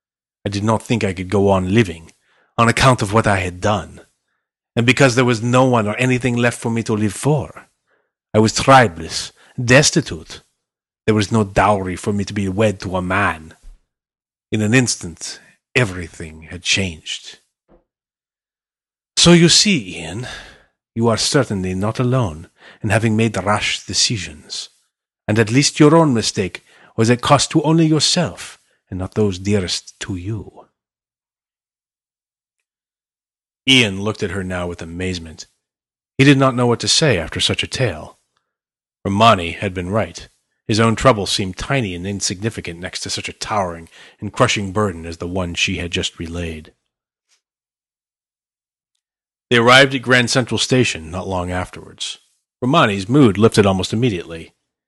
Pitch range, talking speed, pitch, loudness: 90-120 Hz, 155 wpm, 105 Hz, -16 LUFS